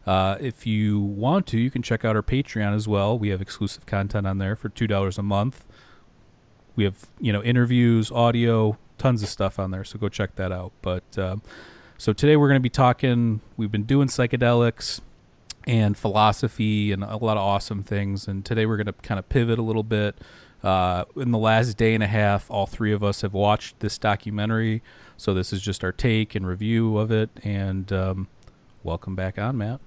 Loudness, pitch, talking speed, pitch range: -24 LUFS, 105 Hz, 210 wpm, 100-115 Hz